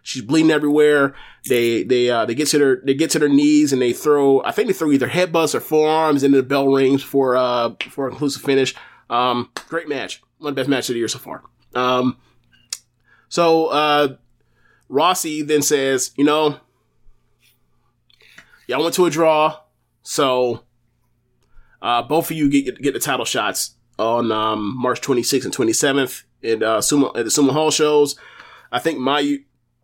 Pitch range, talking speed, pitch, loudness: 125-150 Hz, 180 wpm, 135 Hz, -18 LUFS